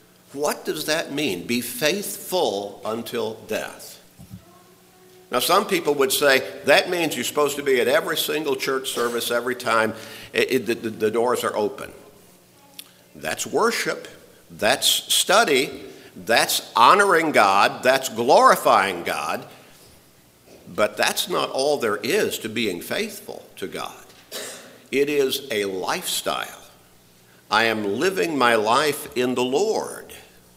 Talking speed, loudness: 130 wpm, -21 LUFS